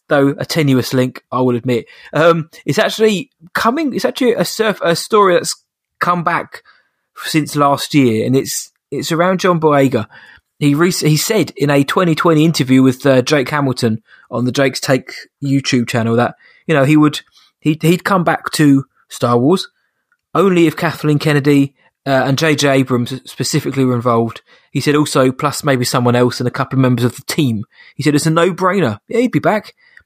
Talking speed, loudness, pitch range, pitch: 190 wpm, -14 LUFS, 130-170 Hz, 145 Hz